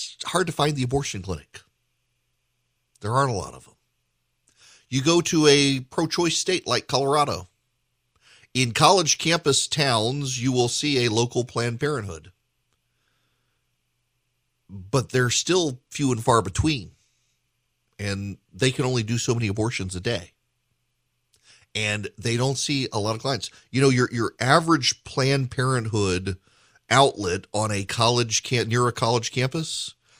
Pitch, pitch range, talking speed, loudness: 125 Hz, 110-135 Hz, 145 wpm, -23 LUFS